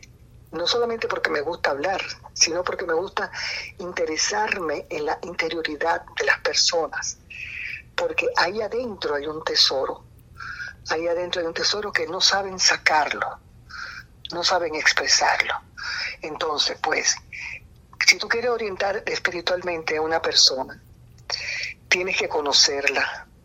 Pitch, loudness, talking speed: 205 Hz, -22 LUFS, 125 wpm